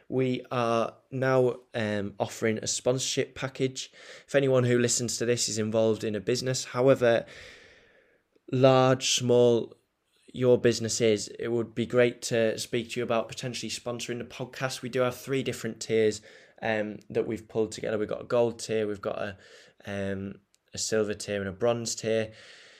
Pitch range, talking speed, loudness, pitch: 110-130 Hz, 170 wpm, -28 LUFS, 120 Hz